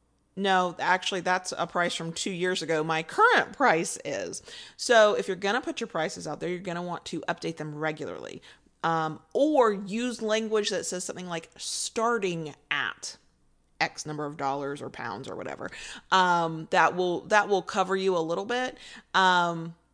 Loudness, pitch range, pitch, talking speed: -27 LUFS, 165-200 Hz, 180 Hz, 175 wpm